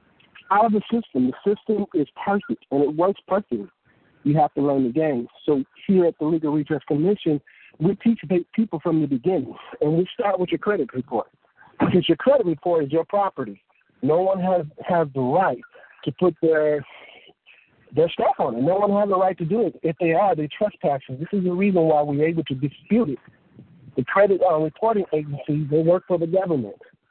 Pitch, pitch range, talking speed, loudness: 165 Hz, 150-200 Hz, 195 wpm, -22 LUFS